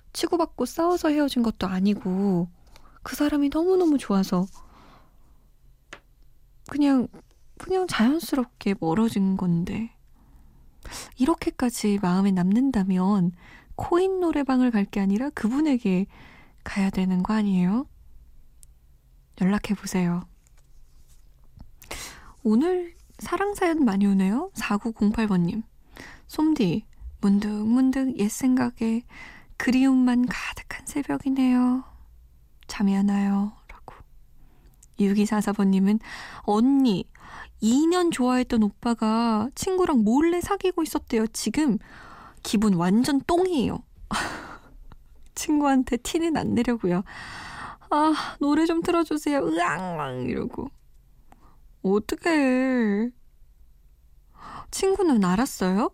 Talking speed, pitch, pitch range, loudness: 210 characters per minute, 225 Hz, 190-280 Hz, -24 LUFS